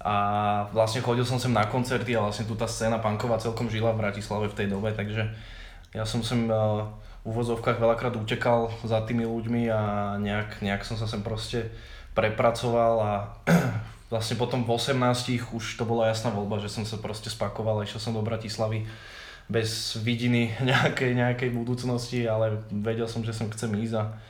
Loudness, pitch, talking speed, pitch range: -27 LUFS, 115 Hz, 180 wpm, 110-120 Hz